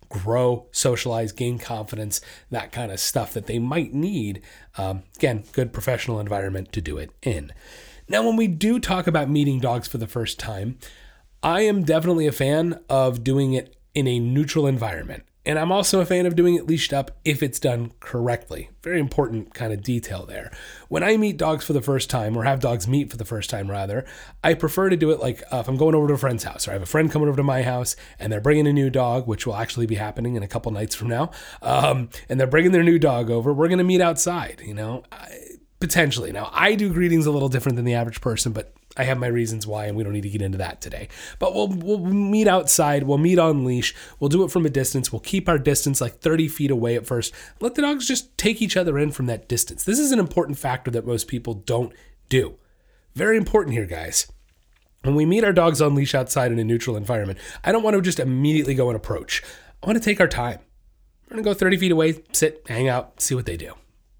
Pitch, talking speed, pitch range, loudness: 130 Hz, 240 wpm, 115-165 Hz, -22 LUFS